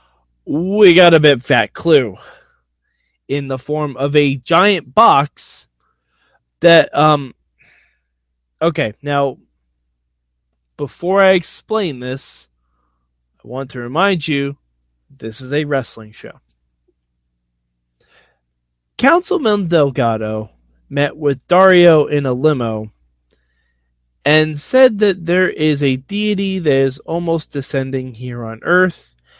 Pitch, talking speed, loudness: 135 Hz, 110 wpm, -15 LUFS